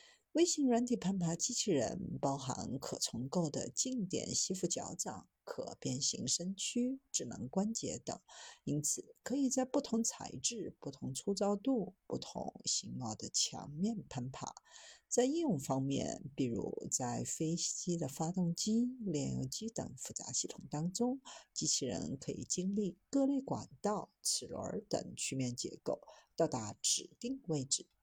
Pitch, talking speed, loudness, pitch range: 190 Hz, 220 characters per minute, -37 LUFS, 155-245 Hz